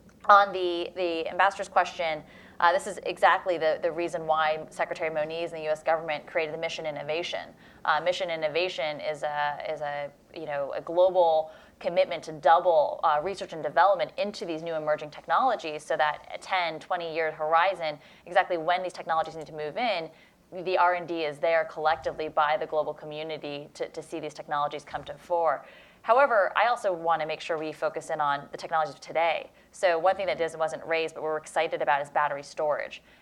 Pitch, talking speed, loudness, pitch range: 160 Hz, 190 wpm, -27 LUFS, 155-175 Hz